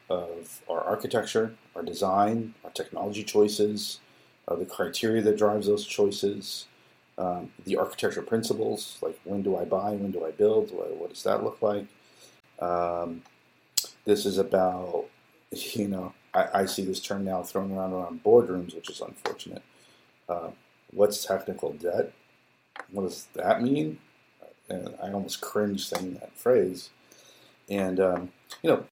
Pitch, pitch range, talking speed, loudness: 100 Hz, 90-105 Hz, 150 wpm, -28 LUFS